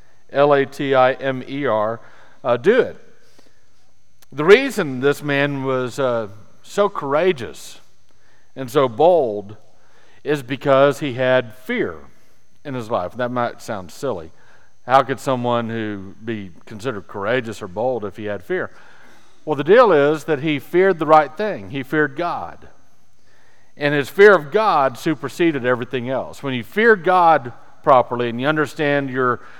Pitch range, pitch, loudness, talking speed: 120-150 Hz, 135 Hz, -18 LUFS, 155 wpm